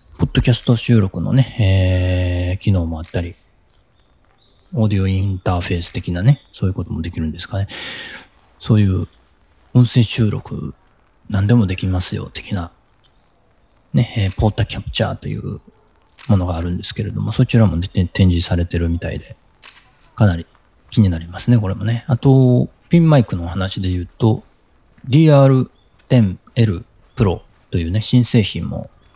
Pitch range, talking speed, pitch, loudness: 90-115 Hz, 310 characters per minute, 100 Hz, -17 LUFS